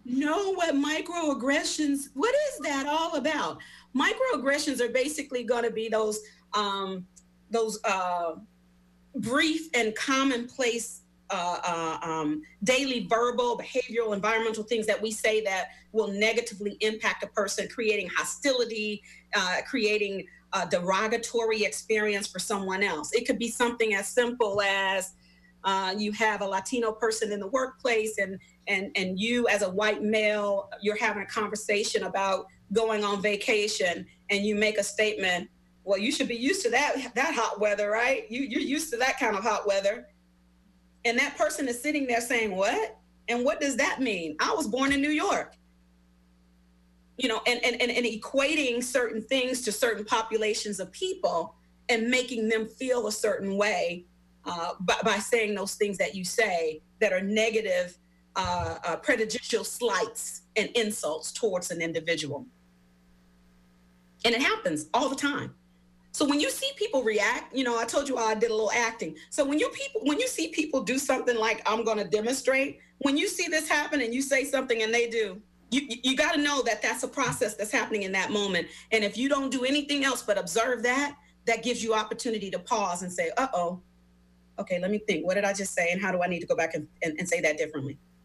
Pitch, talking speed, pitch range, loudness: 220 Hz, 185 wpm, 190-255 Hz, -27 LUFS